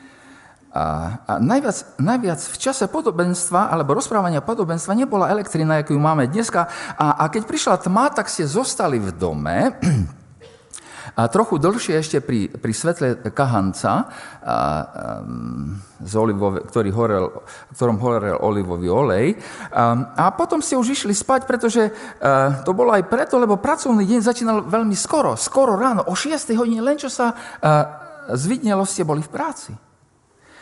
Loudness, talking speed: -20 LUFS, 145 wpm